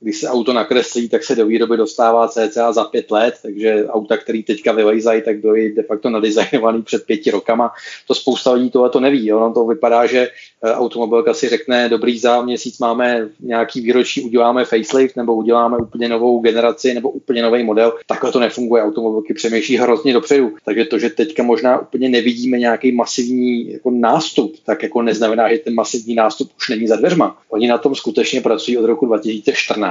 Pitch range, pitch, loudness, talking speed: 115-125 Hz, 120 Hz, -15 LUFS, 185 wpm